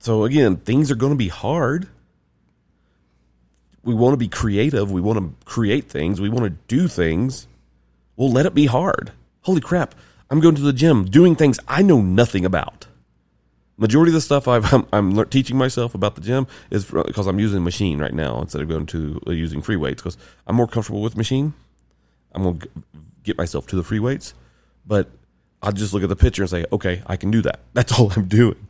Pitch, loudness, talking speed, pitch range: 105 Hz, -19 LUFS, 215 wpm, 80-130 Hz